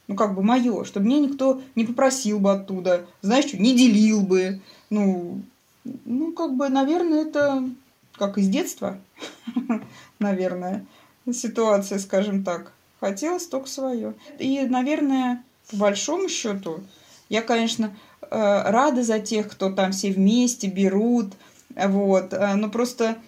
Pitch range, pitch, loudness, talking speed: 200-260 Hz, 225 Hz, -23 LUFS, 130 wpm